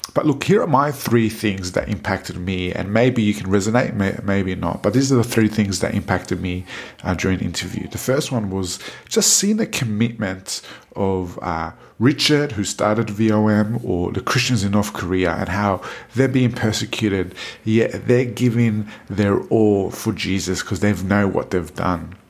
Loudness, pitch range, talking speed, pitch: -20 LUFS, 95-115 Hz, 185 wpm, 105 Hz